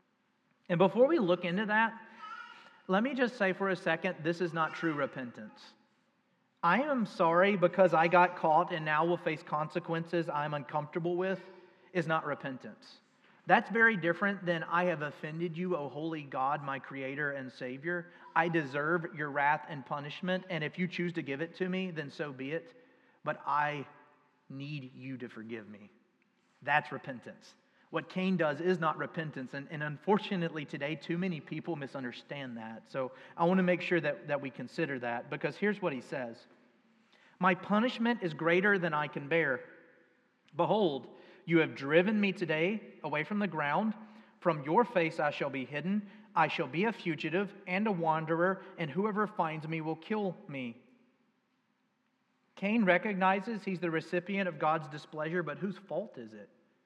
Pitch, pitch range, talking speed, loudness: 170 Hz, 150-190 Hz, 170 wpm, -32 LUFS